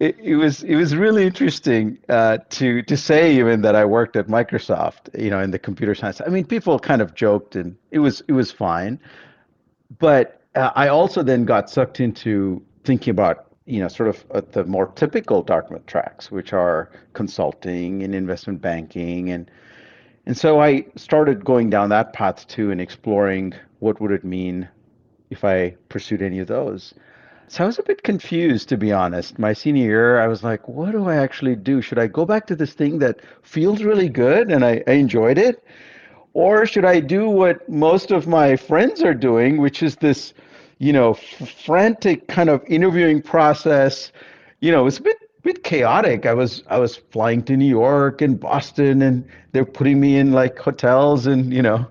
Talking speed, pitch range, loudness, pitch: 195 wpm, 110-155 Hz, -18 LUFS, 130 Hz